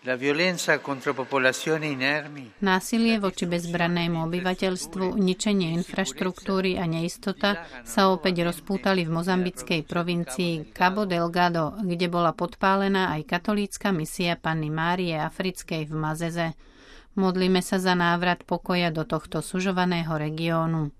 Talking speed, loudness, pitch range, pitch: 105 wpm, -25 LUFS, 160-190 Hz, 175 Hz